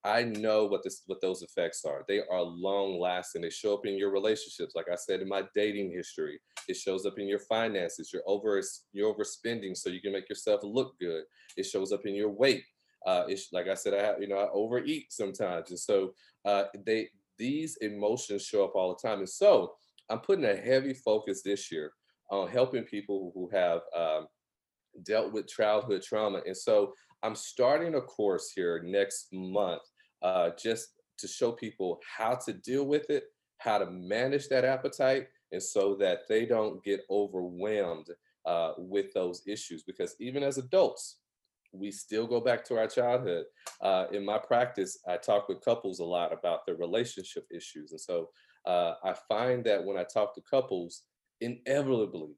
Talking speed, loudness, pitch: 185 wpm, -32 LUFS, 145 Hz